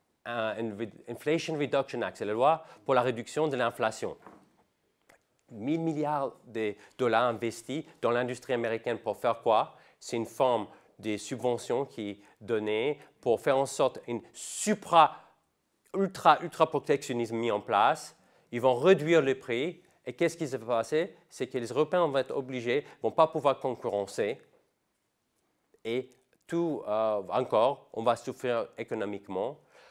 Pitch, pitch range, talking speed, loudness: 125 Hz, 115-155 Hz, 140 wpm, -30 LUFS